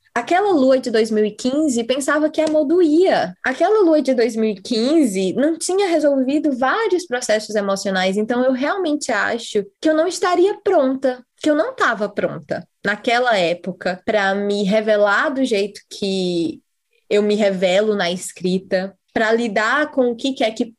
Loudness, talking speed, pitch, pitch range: -18 LUFS, 145 wpm, 245 Hz, 210-305 Hz